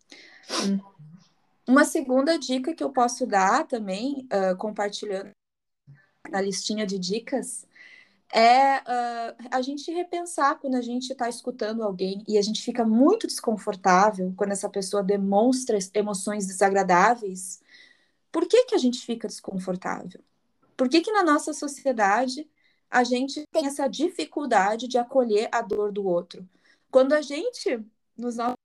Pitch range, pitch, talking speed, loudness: 200-275 Hz, 235 Hz, 140 wpm, -25 LUFS